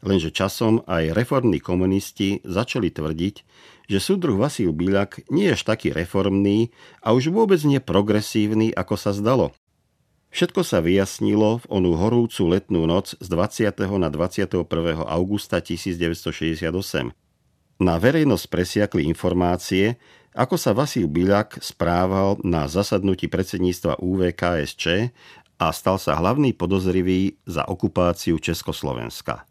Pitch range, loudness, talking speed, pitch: 85-105 Hz, -22 LUFS, 120 wpm, 95 Hz